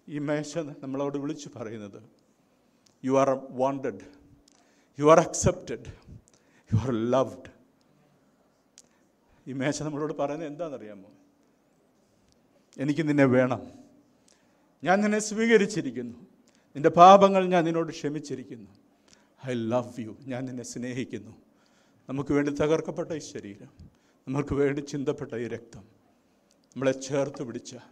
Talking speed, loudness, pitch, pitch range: 105 wpm, -26 LUFS, 145 Hz, 130-165 Hz